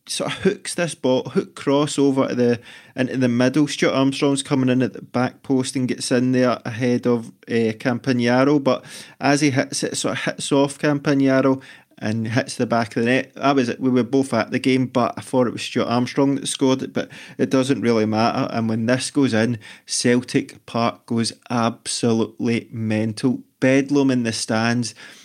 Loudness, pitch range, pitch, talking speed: -20 LUFS, 120-140 Hz, 130 Hz, 195 wpm